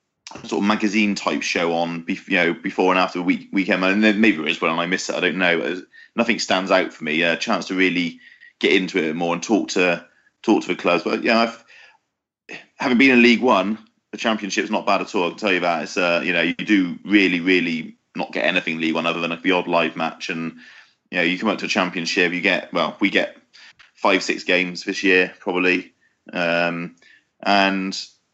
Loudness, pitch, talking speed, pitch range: -20 LUFS, 90 Hz, 230 wpm, 85-105 Hz